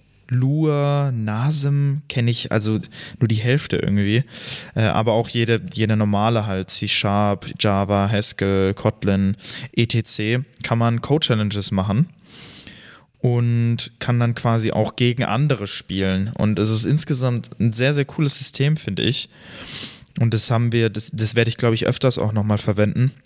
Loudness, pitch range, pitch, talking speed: -20 LUFS, 105-130 Hz, 115 Hz, 155 wpm